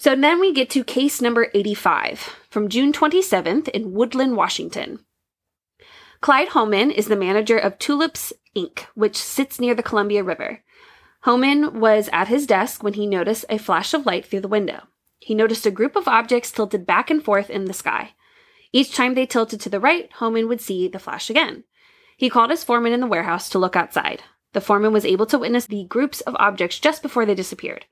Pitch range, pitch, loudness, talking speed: 210-290 Hz, 235 Hz, -20 LUFS, 200 wpm